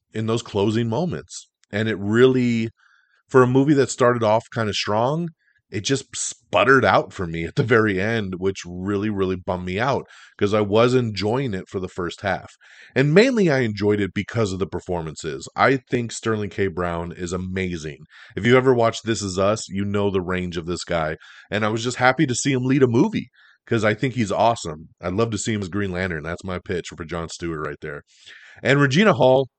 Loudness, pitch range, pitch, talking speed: -21 LUFS, 95-125 Hz, 105 Hz, 215 wpm